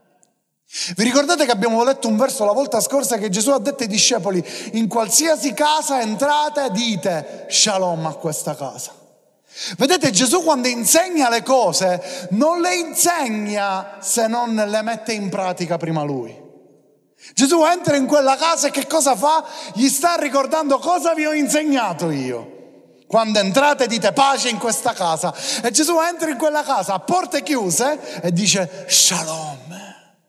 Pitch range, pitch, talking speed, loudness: 195-295 Hz, 240 Hz, 155 wpm, -18 LUFS